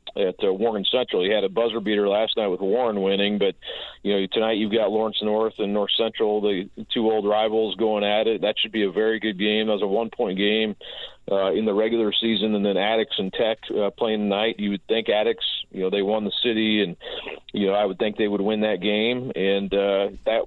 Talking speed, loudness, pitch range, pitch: 235 wpm, -23 LUFS, 100-110 Hz, 105 Hz